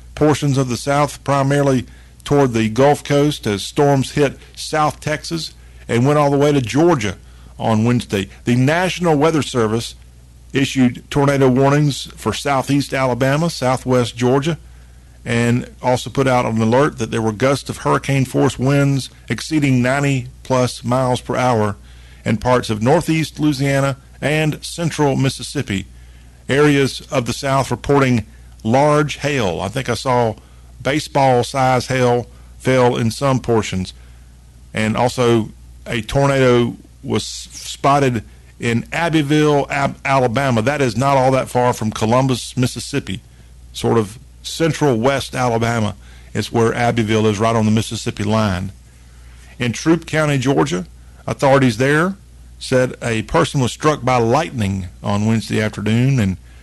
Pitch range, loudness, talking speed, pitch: 110-140 Hz, -17 LUFS, 140 wpm, 125 Hz